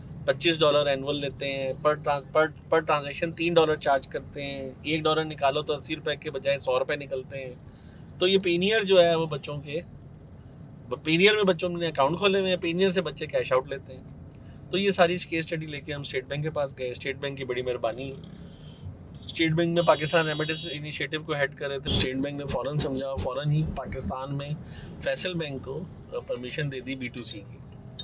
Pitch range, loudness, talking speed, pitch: 135-165 Hz, -27 LUFS, 210 wpm, 145 Hz